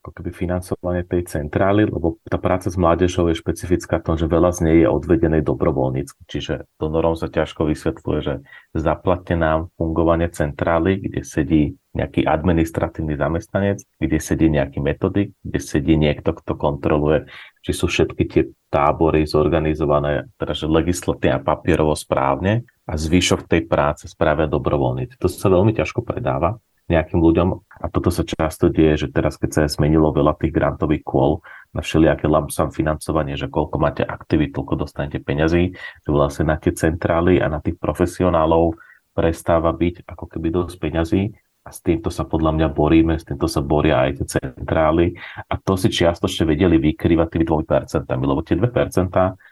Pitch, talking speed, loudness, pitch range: 85 Hz, 165 wpm, -20 LUFS, 80-90 Hz